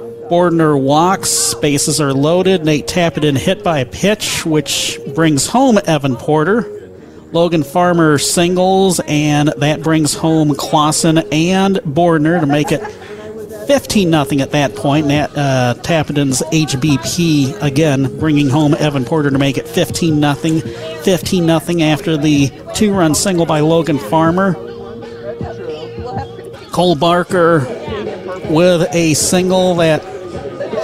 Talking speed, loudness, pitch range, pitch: 115 wpm, -13 LUFS, 145-175 Hz, 155 Hz